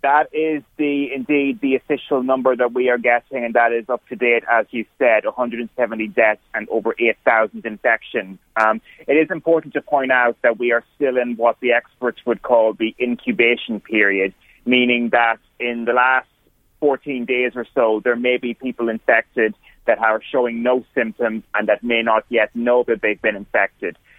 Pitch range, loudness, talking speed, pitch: 115-125 Hz, -19 LUFS, 185 wpm, 120 Hz